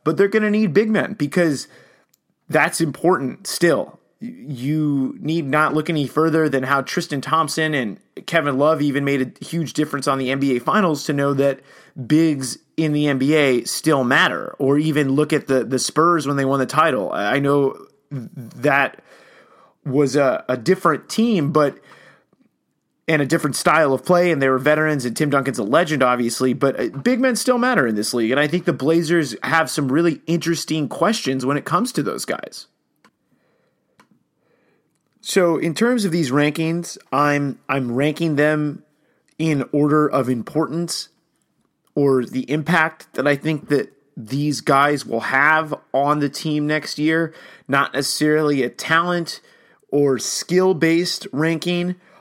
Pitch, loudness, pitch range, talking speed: 150 Hz, -19 LUFS, 140-165 Hz, 160 wpm